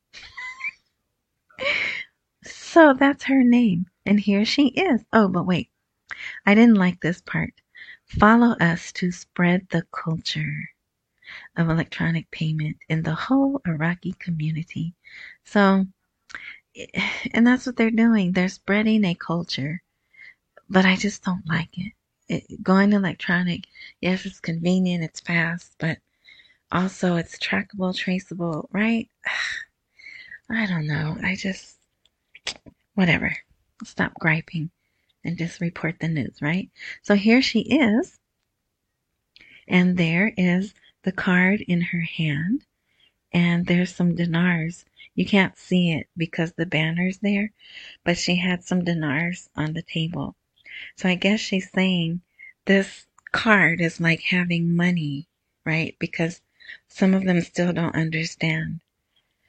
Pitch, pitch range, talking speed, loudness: 180 Hz, 165-205 Hz, 125 wpm, -22 LUFS